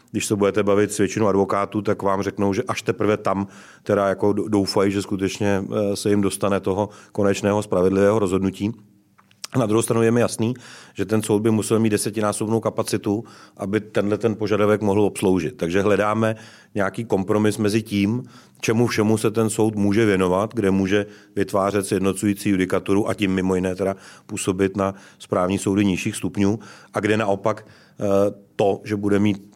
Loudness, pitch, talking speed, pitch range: -21 LUFS, 105 Hz, 165 wpm, 100-110 Hz